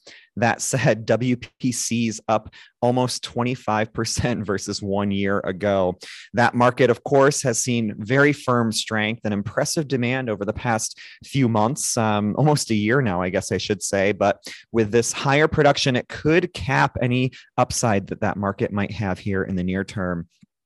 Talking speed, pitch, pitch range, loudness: 165 wpm, 110 Hz, 100-125 Hz, -22 LUFS